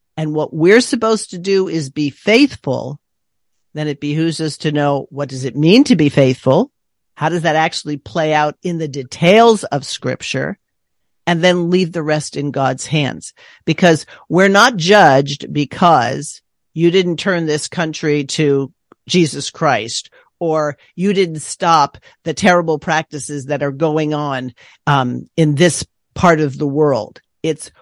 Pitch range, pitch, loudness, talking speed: 145-175 Hz, 155 Hz, -15 LUFS, 155 wpm